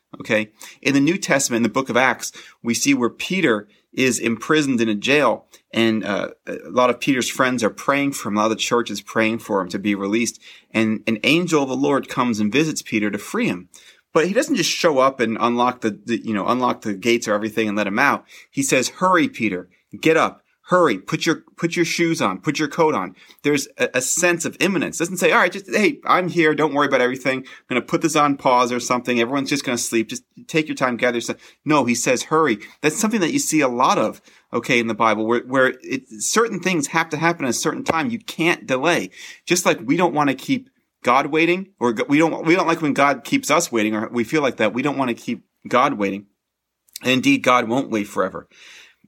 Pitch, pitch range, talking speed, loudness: 135 Hz, 115-165 Hz, 245 wpm, -20 LUFS